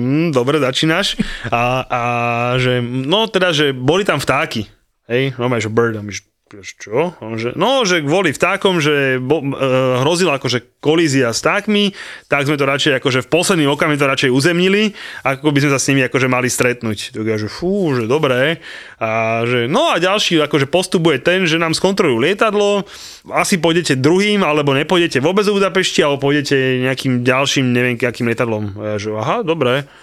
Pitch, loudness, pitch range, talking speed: 140 Hz, -15 LUFS, 125-175 Hz, 170 wpm